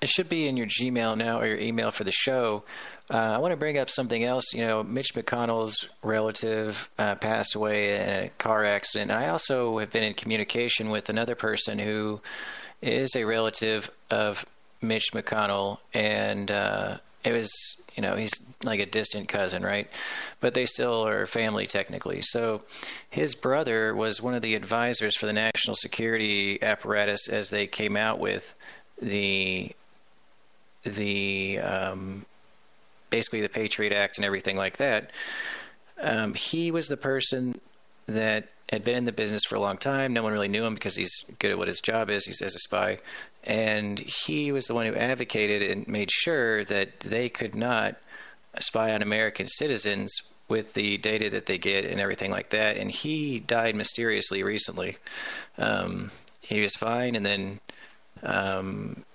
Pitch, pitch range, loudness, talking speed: 110 Hz, 105-120 Hz, -26 LUFS, 170 wpm